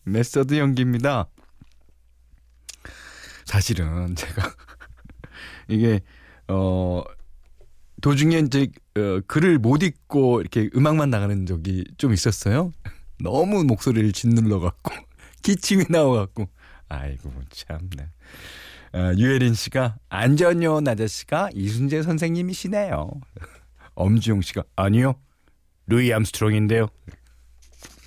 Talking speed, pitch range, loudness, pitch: 225 characters per minute, 85-135 Hz, -22 LUFS, 105 Hz